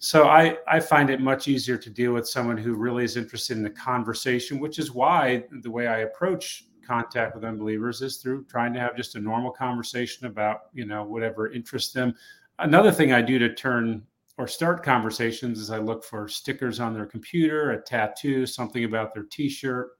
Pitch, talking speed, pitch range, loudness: 120 Hz, 200 wpm, 115-135 Hz, -25 LUFS